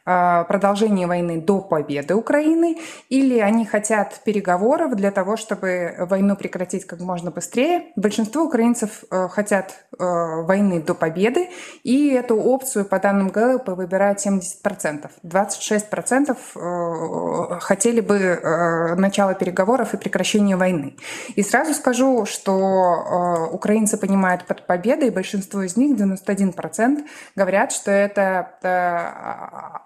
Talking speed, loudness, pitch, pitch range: 110 wpm, -20 LUFS, 200 Hz, 180-230 Hz